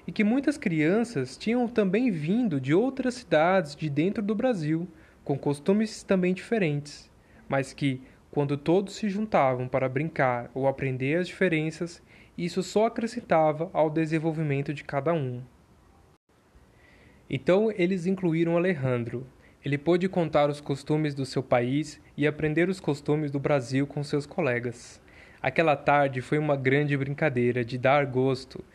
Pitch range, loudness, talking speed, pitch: 135-185 Hz, -27 LUFS, 140 wpm, 150 Hz